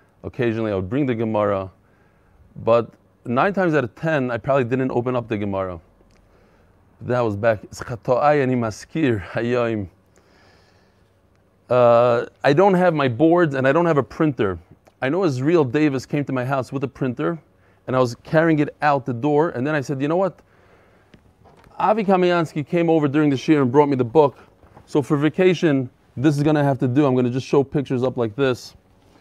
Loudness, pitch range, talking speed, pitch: -20 LUFS, 95-150 Hz, 185 wpm, 125 Hz